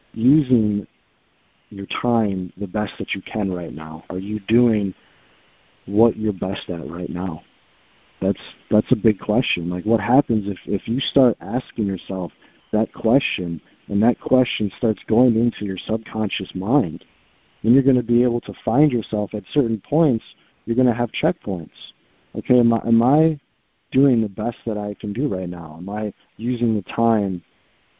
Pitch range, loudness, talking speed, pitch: 95-120 Hz, -21 LUFS, 170 wpm, 110 Hz